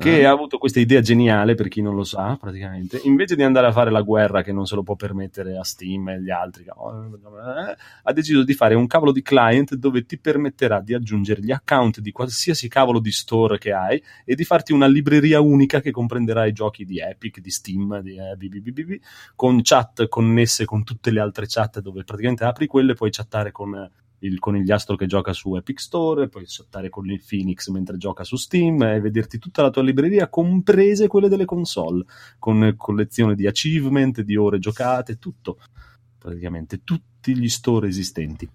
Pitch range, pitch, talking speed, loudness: 100-135 Hz, 115 Hz, 200 wpm, -19 LUFS